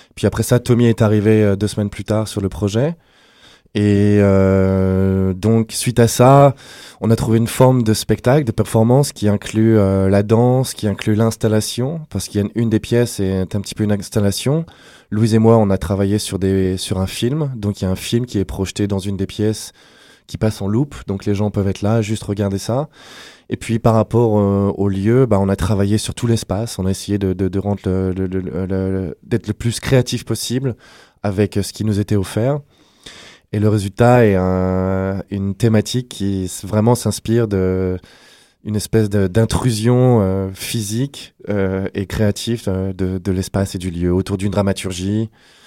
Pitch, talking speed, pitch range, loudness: 105 Hz, 195 wpm, 95-115 Hz, -17 LUFS